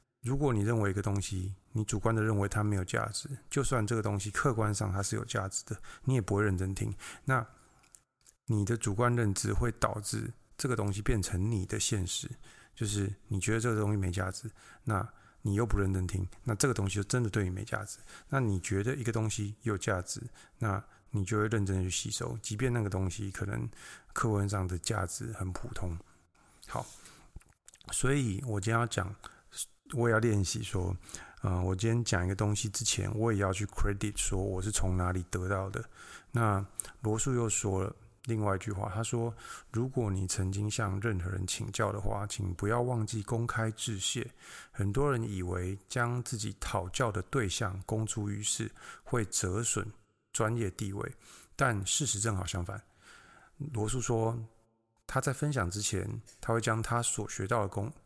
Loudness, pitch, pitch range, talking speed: -33 LUFS, 110 Hz, 100-115 Hz, 270 characters per minute